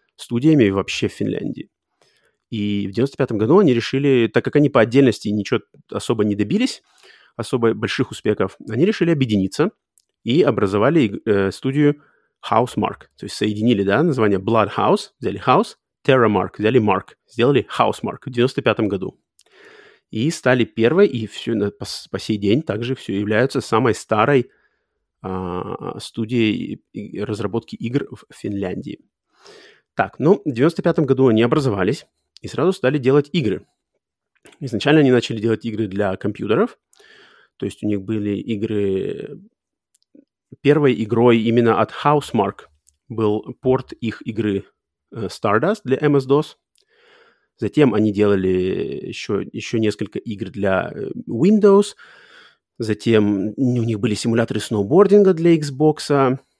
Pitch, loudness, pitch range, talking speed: 115 Hz, -19 LUFS, 105-140 Hz, 130 wpm